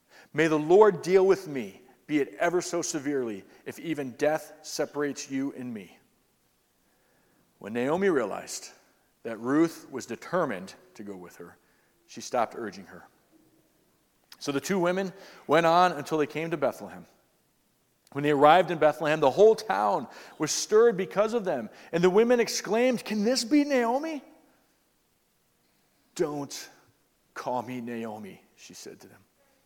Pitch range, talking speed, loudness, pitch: 150-210 Hz, 150 wpm, -26 LUFS, 165 Hz